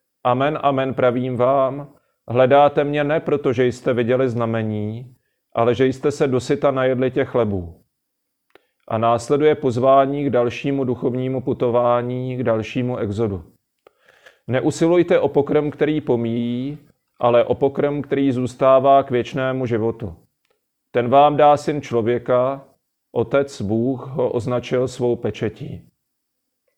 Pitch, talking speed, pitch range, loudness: 130 Hz, 120 wpm, 120-140 Hz, -19 LUFS